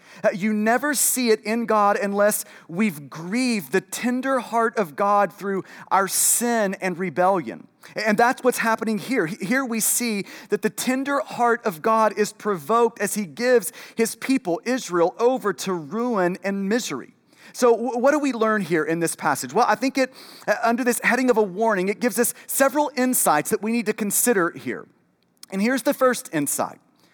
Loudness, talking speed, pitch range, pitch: -22 LUFS, 180 wpm, 200-245 Hz, 220 Hz